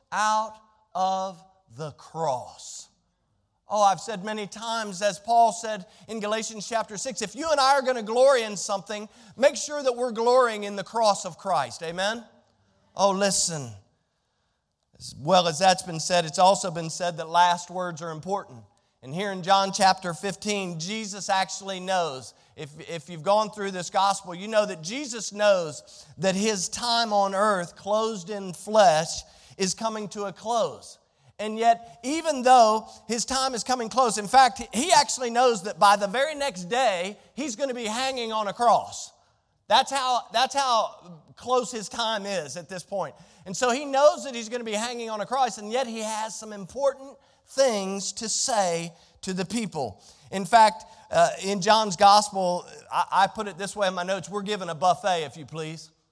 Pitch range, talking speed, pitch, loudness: 185-230 Hz, 185 wpm, 205 Hz, -25 LUFS